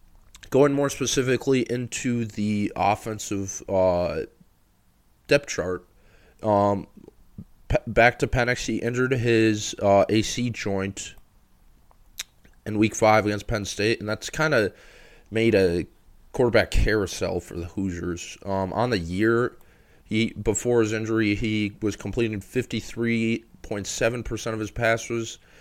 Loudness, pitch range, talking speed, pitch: -24 LUFS, 100-115 Hz, 120 wpm, 110 Hz